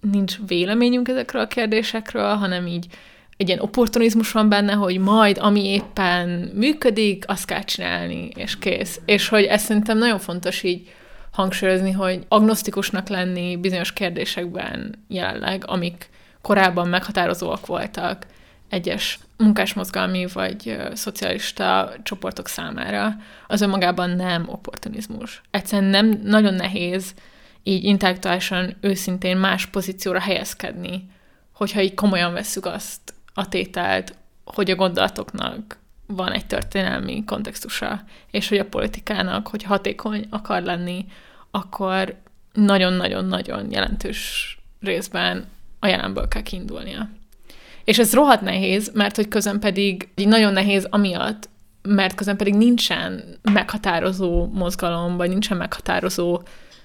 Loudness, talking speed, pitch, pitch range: -21 LUFS, 115 wpm, 195 Hz, 185-210 Hz